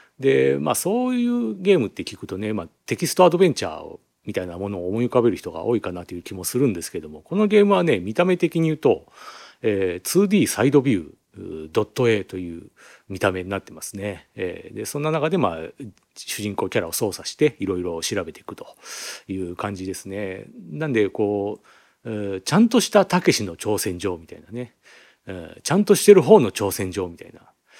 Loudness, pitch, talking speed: -21 LUFS, 110 Hz, 370 characters per minute